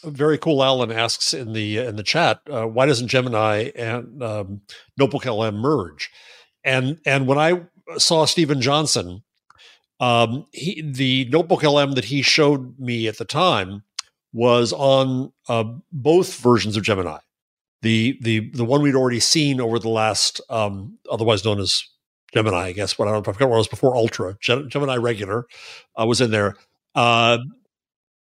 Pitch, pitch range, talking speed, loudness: 120 Hz, 110-140 Hz, 165 wpm, -20 LUFS